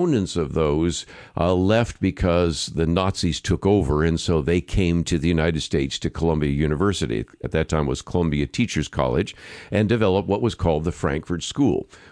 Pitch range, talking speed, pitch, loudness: 80-95 Hz, 175 wpm, 85 Hz, -22 LUFS